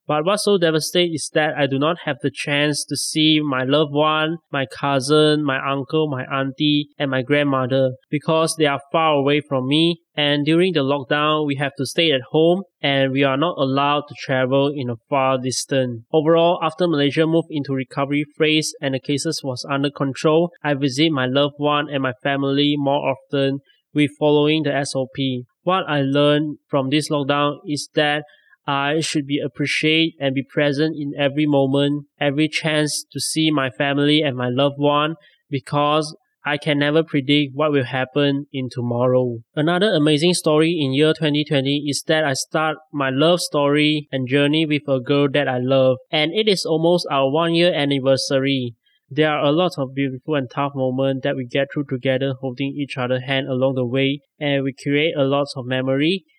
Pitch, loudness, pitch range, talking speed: 145 Hz, -19 LUFS, 135-155 Hz, 185 wpm